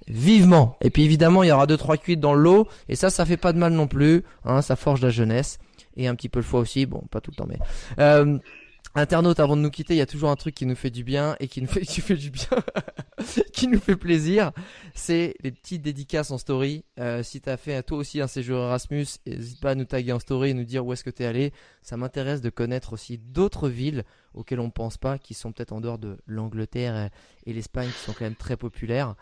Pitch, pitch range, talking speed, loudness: 135 Hz, 120-155 Hz, 260 wpm, -23 LUFS